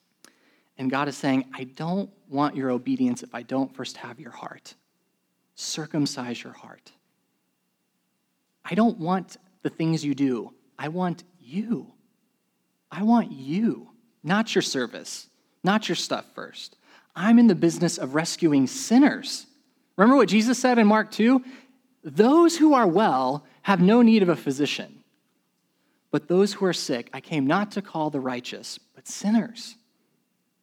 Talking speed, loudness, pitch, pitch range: 150 wpm, -23 LUFS, 190 Hz, 145-230 Hz